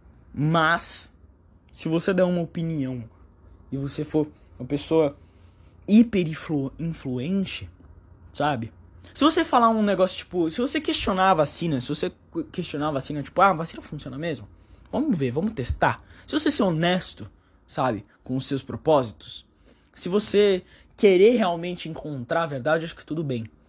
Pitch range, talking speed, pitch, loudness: 110-180 Hz, 150 wpm, 150 Hz, -24 LUFS